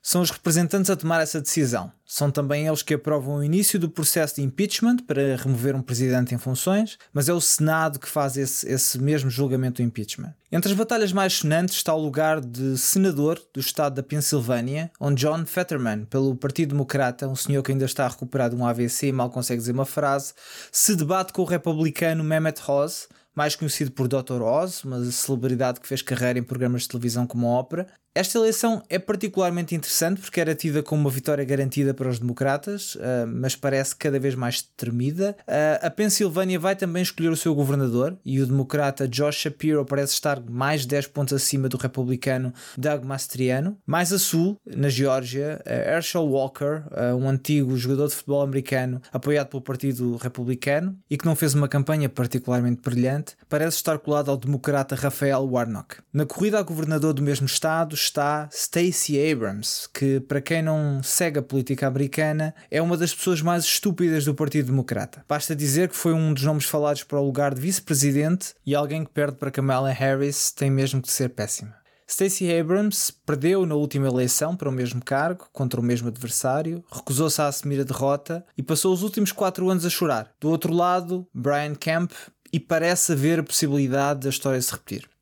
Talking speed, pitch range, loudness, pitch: 185 wpm, 135-165 Hz, -24 LUFS, 145 Hz